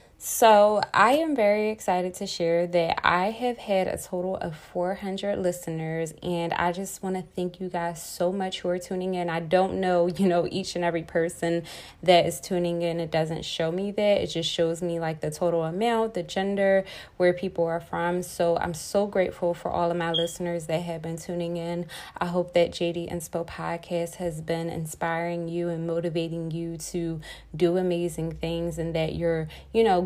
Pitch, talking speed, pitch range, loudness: 175 Hz, 195 wpm, 170-185 Hz, -26 LUFS